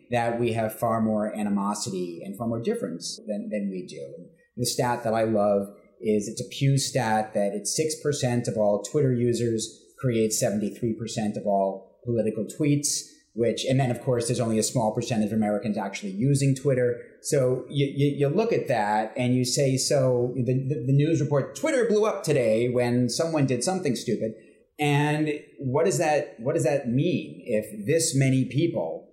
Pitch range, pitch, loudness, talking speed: 110-140 Hz, 120 Hz, -25 LUFS, 185 wpm